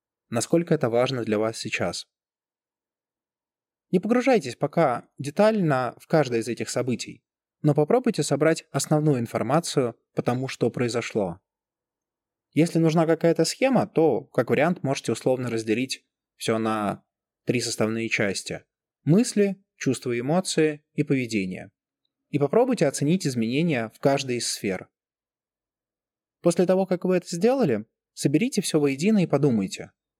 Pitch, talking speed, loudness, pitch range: 145 Hz, 125 wpm, -24 LUFS, 120-170 Hz